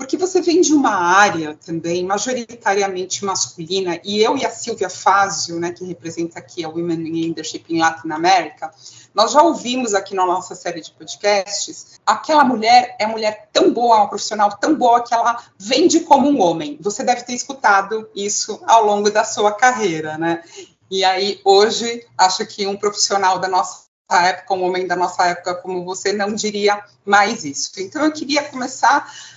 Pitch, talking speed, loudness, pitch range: 205 Hz, 180 wpm, -17 LUFS, 180-240 Hz